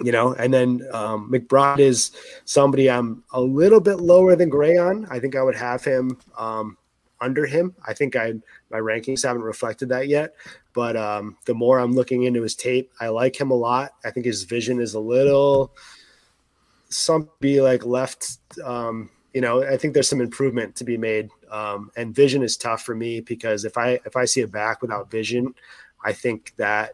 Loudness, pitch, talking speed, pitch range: -21 LUFS, 125 Hz, 200 wpm, 115-135 Hz